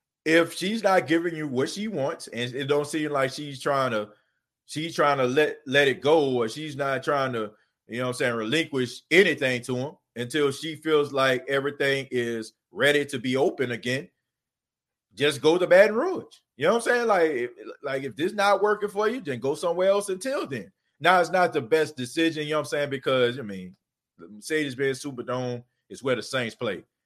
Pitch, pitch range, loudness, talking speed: 140 Hz, 125-165 Hz, -25 LUFS, 215 wpm